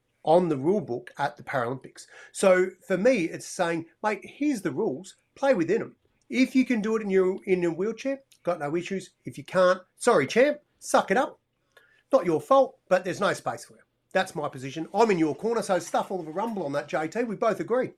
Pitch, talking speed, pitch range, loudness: 190 Hz, 225 wpm, 170-230 Hz, -26 LUFS